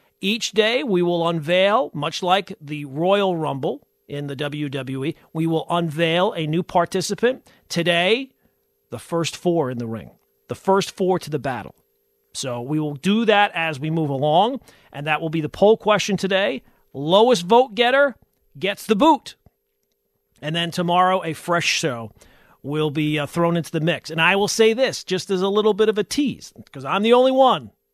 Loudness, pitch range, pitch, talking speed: -20 LUFS, 155-205 Hz, 175 Hz, 185 wpm